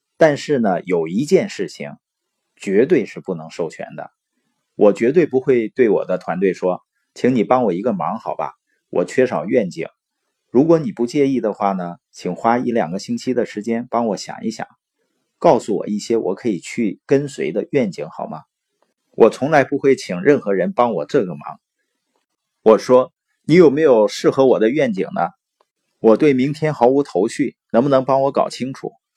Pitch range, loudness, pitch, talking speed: 115-145 Hz, -18 LUFS, 130 Hz, 255 characters per minute